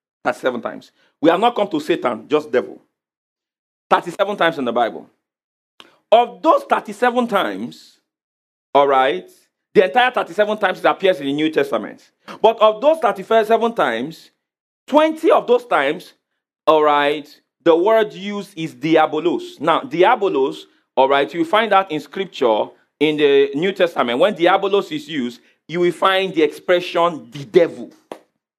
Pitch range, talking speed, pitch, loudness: 150-225 Hz, 150 wpm, 185 Hz, -17 LUFS